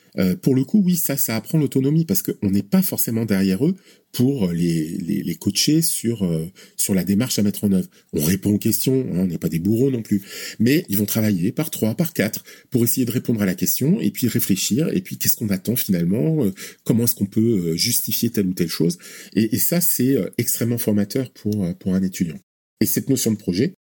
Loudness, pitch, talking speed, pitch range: -20 LUFS, 110 Hz, 230 wpm, 95-135 Hz